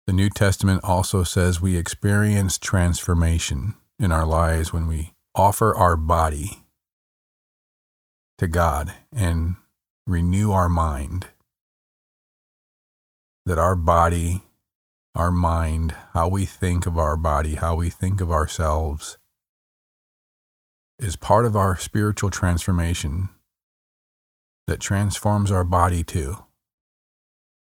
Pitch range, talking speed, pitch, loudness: 80-95 Hz, 105 wpm, 90 Hz, -22 LUFS